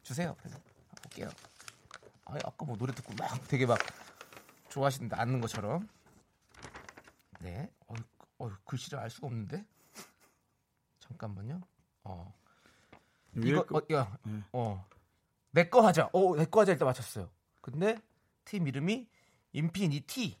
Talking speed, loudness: 225 characters per minute, -33 LUFS